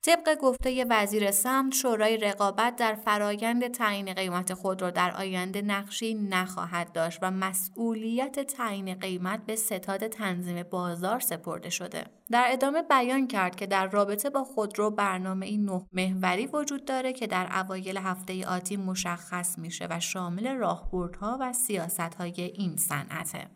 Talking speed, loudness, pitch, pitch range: 150 wpm, -29 LUFS, 200 Hz, 185-230 Hz